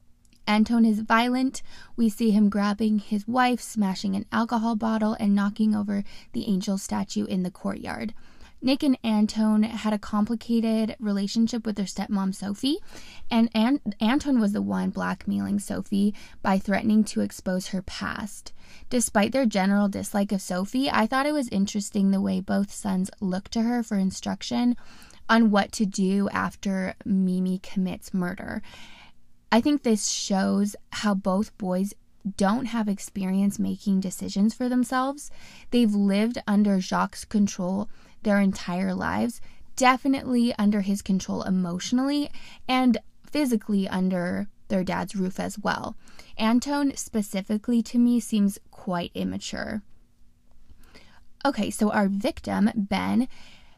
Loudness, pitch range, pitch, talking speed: -25 LUFS, 195-230 Hz, 210 Hz, 135 wpm